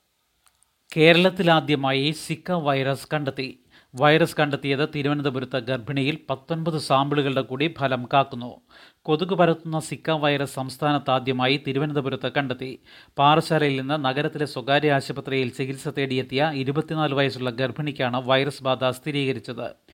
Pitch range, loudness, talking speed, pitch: 130-150 Hz, -23 LUFS, 100 wpm, 140 Hz